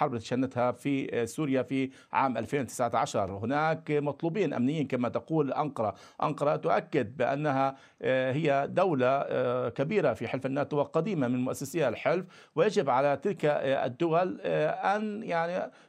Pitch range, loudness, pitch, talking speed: 125-150 Hz, -29 LUFS, 140 Hz, 125 wpm